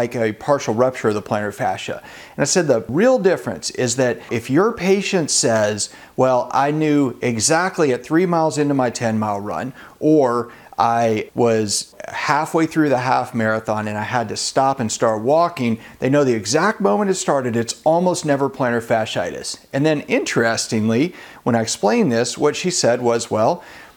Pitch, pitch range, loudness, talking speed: 125 Hz, 115-155 Hz, -19 LUFS, 180 wpm